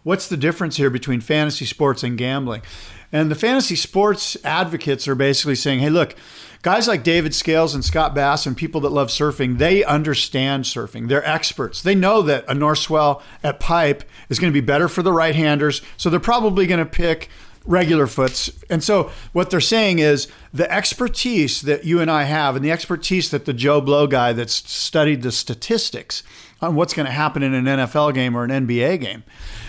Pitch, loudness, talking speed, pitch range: 150 Hz, -18 LUFS, 200 wpm, 135-170 Hz